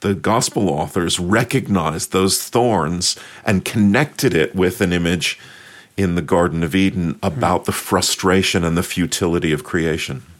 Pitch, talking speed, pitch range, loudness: 90 Hz, 145 wpm, 85-100 Hz, -18 LUFS